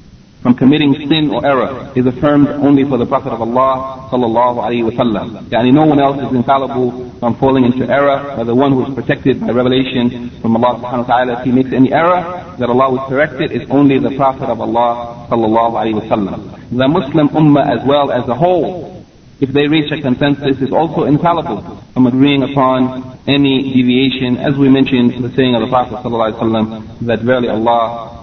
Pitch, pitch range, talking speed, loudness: 130 Hz, 120-140 Hz, 190 wpm, -13 LUFS